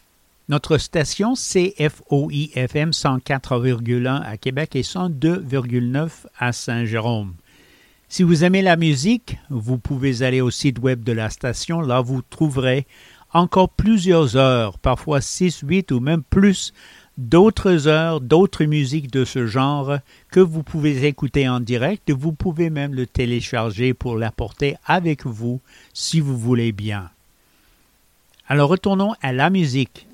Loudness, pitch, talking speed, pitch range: -19 LUFS, 140 Hz, 135 wpm, 125-165 Hz